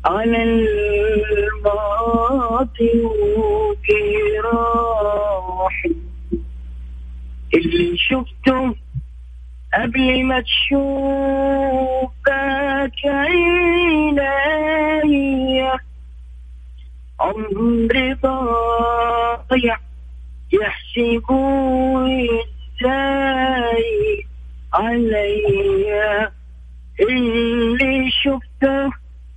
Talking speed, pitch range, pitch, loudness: 35 wpm, 200-270 Hz, 235 Hz, -18 LUFS